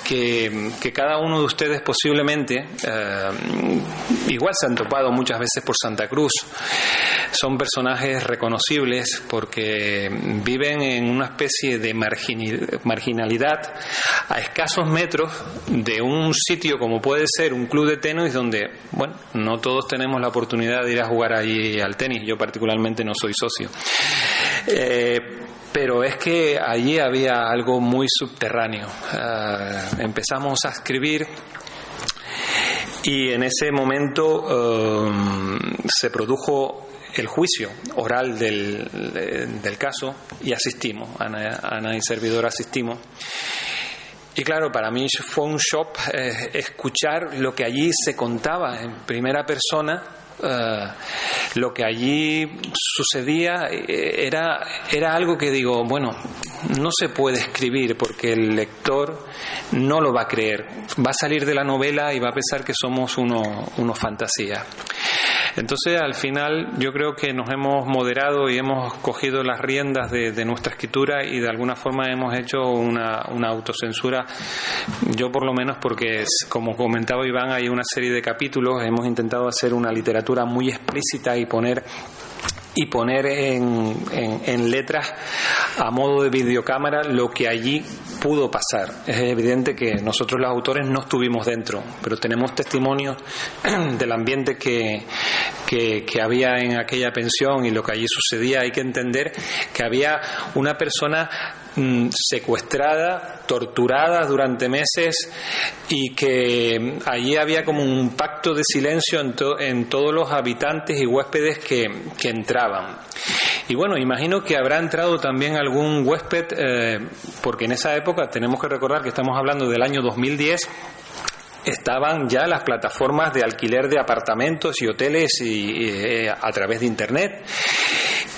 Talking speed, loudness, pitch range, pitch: 145 wpm, -21 LUFS, 115-145 Hz, 130 Hz